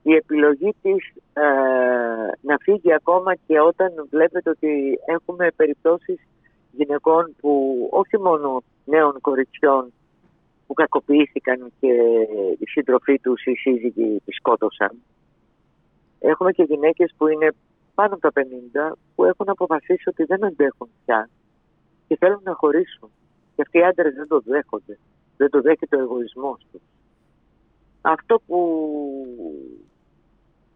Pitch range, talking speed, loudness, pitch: 135-175 Hz, 125 wpm, -20 LUFS, 150 Hz